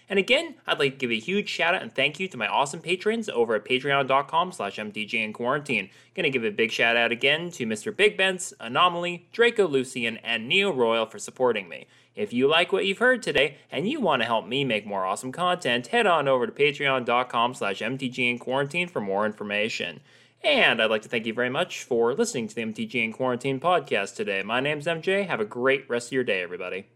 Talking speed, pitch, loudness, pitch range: 205 wpm, 135 Hz, -25 LUFS, 120-190 Hz